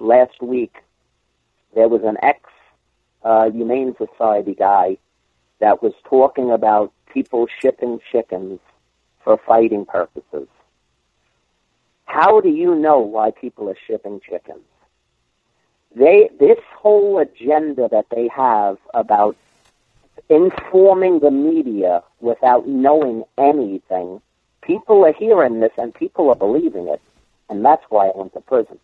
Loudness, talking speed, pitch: -16 LUFS, 125 wpm, 125 Hz